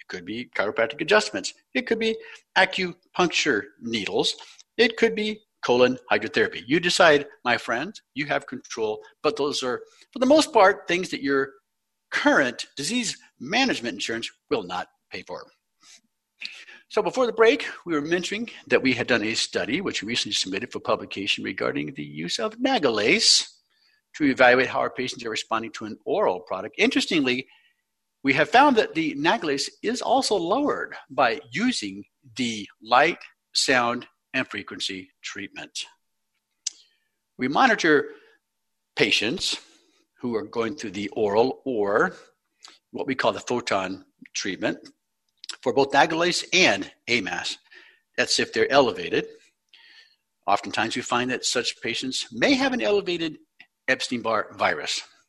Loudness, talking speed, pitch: -23 LUFS, 140 wpm, 245 Hz